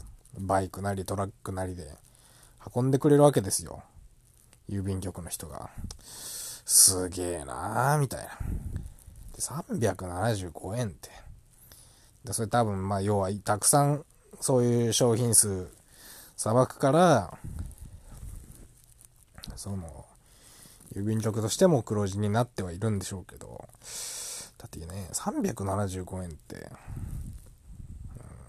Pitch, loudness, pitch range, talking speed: 105 Hz, -27 LUFS, 95-120 Hz, 210 characters per minute